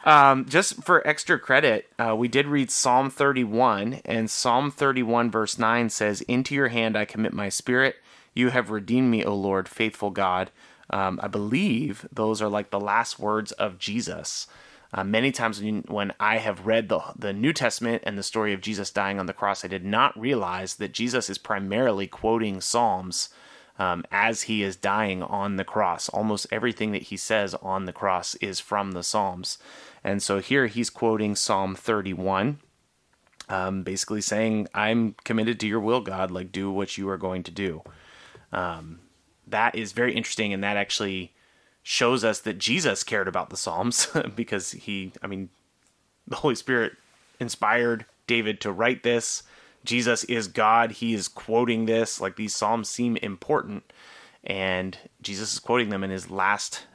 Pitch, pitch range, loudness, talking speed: 110 Hz, 95-115 Hz, -25 LUFS, 175 wpm